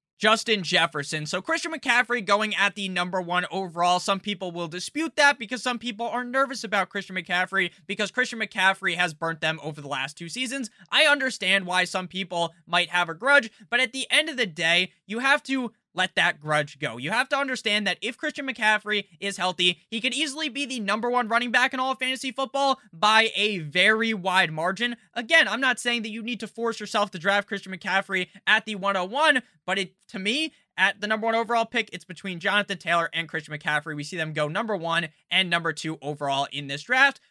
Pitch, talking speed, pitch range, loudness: 200 Hz, 215 wpm, 180-245 Hz, -24 LUFS